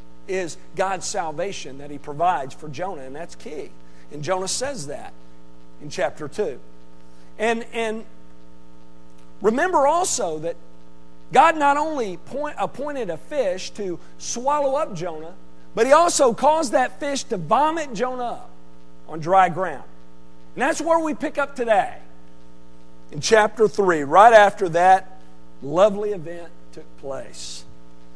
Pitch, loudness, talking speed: 175 Hz, -21 LUFS, 135 wpm